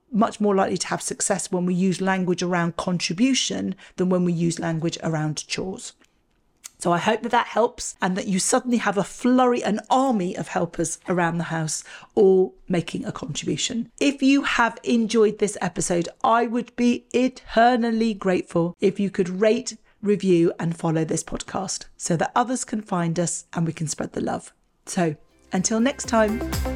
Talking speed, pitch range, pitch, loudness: 175 wpm, 170-230 Hz, 190 Hz, -23 LUFS